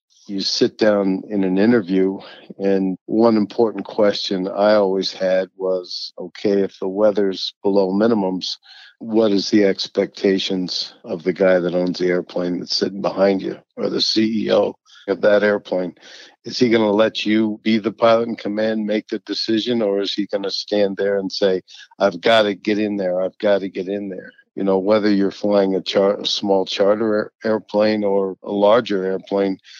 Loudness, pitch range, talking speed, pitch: -19 LUFS, 95-105 Hz, 185 wpm, 100 Hz